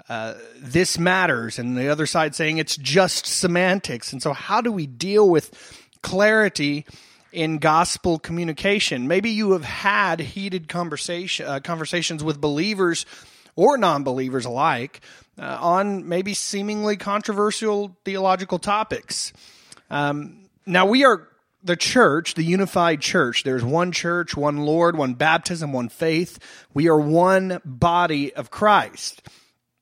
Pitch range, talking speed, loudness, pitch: 150-190 Hz, 135 wpm, -21 LUFS, 170 Hz